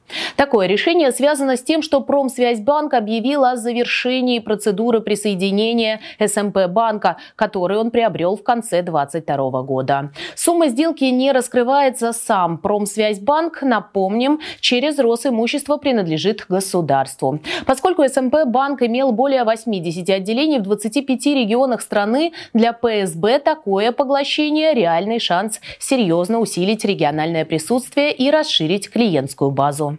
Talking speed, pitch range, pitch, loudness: 115 wpm, 195-270 Hz, 230 Hz, -17 LUFS